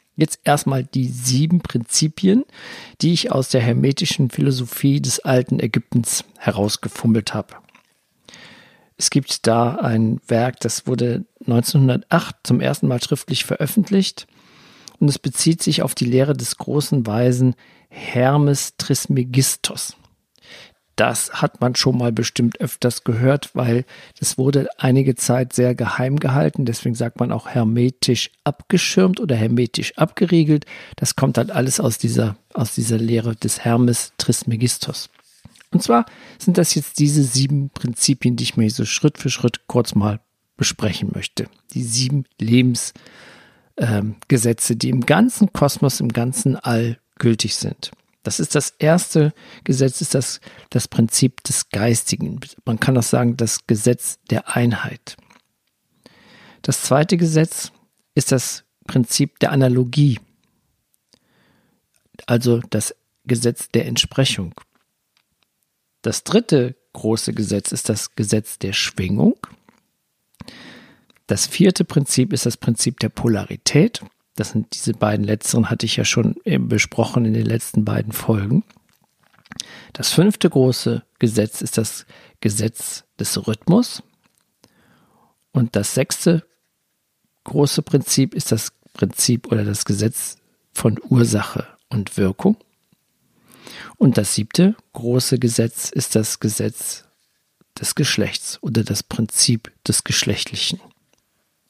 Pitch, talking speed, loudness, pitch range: 125 Hz, 125 wpm, -19 LUFS, 115-145 Hz